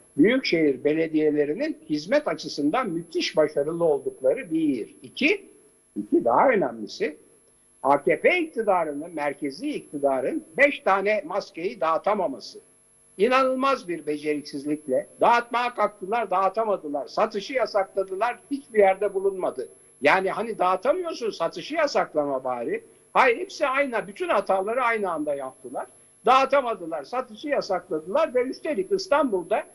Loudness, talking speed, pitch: -24 LUFS, 105 wpm, 235 Hz